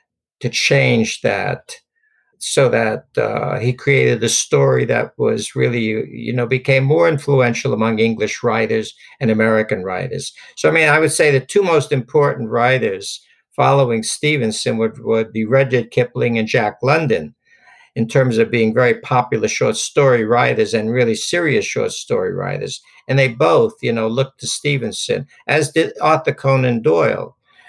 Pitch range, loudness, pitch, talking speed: 115-155 Hz, -16 LUFS, 130 Hz, 160 wpm